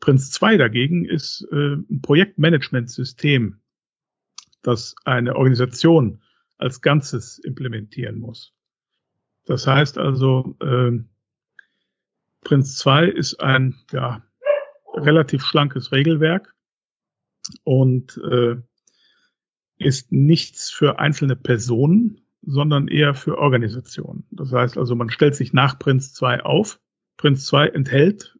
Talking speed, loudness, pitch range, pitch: 105 wpm, -19 LUFS, 125-150 Hz, 135 Hz